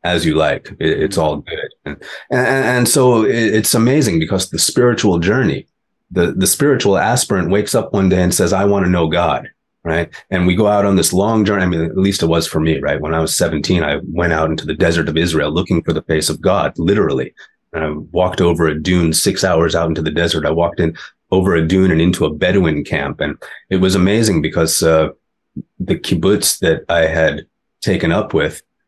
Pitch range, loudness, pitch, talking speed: 80-100 Hz, -15 LUFS, 85 Hz, 220 wpm